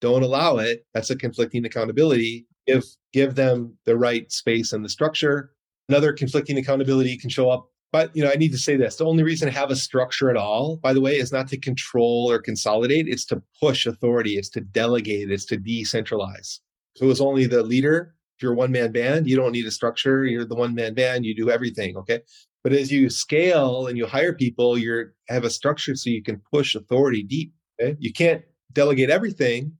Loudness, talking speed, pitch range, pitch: -22 LUFS, 210 wpm, 115-140 Hz, 130 Hz